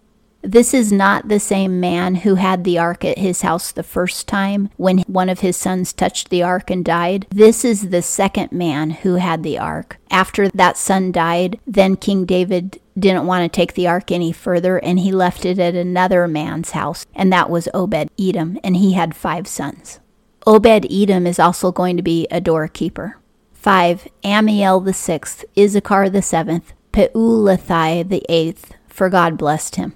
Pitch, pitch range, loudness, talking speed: 185 Hz, 175-195 Hz, -16 LUFS, 180 wpm